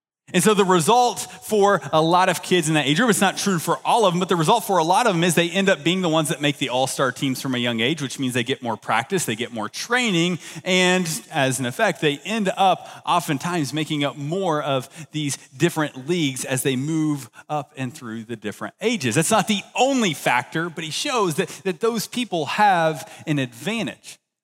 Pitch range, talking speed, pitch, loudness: 140-190 Hz, 230 wpm, 160 Hz, -21 LUFS